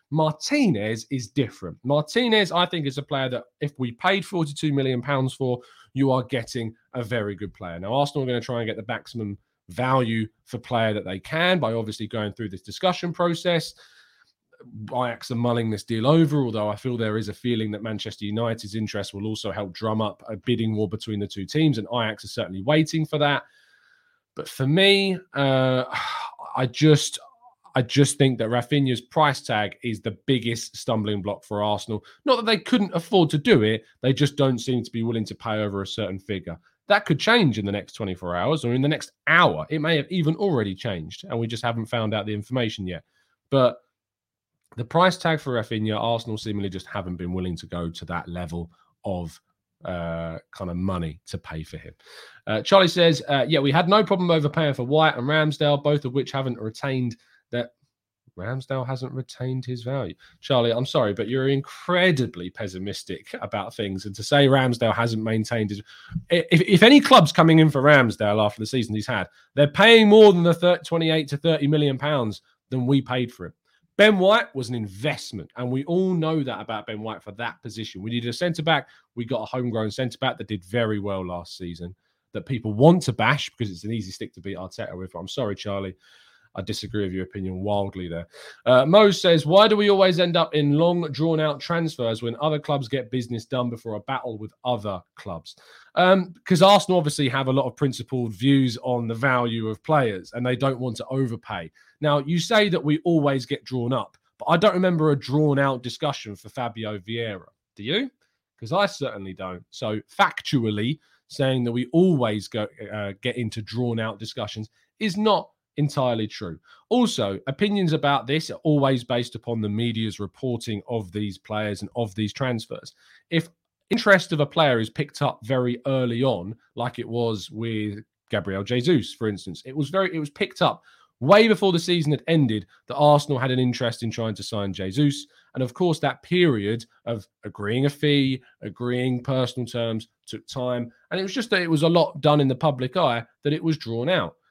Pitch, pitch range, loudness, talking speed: 125 Hz, 110-150 Hz, -23 LUFS, 200 wpm